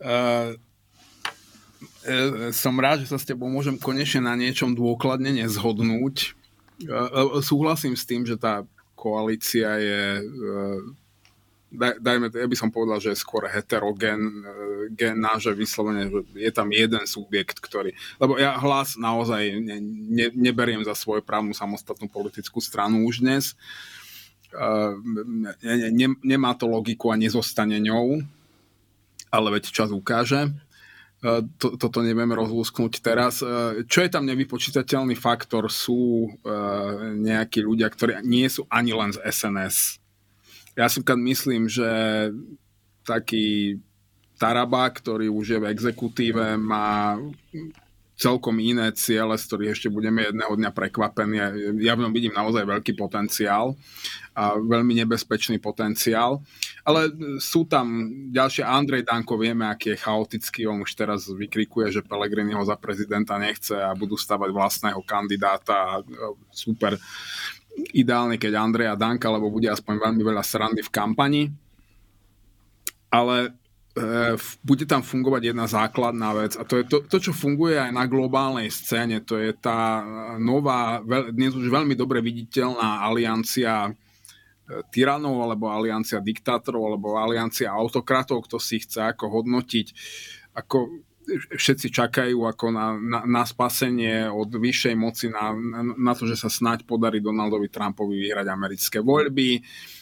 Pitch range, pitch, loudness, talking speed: 105-125 Hz, 115 Hz, -24 LUFS, 135 wpm